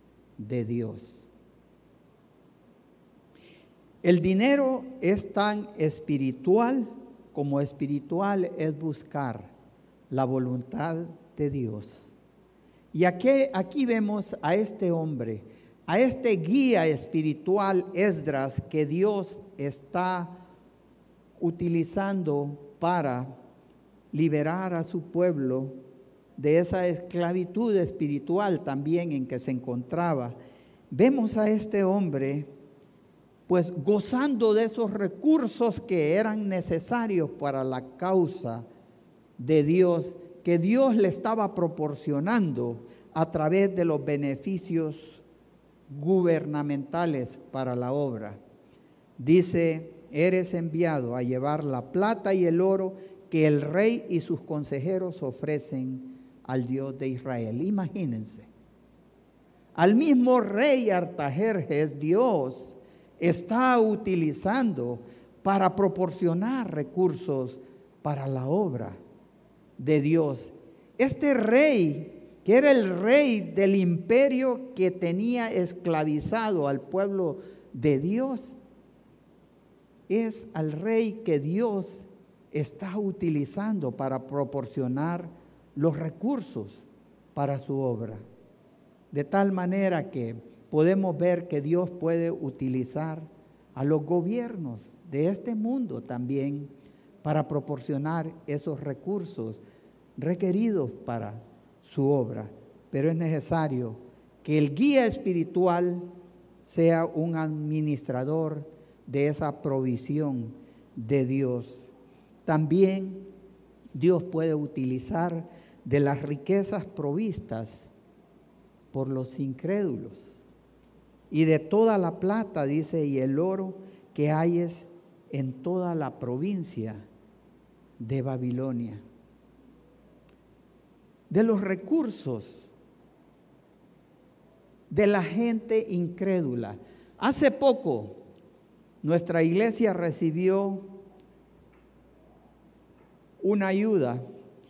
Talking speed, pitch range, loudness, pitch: 95 wpm, 140-195 Hz, -27 LUFS, 165 Hz